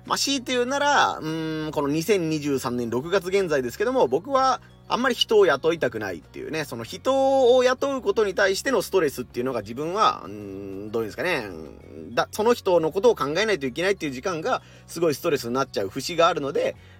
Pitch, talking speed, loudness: 195 Hz, 425 characters per minute, -23 LUFS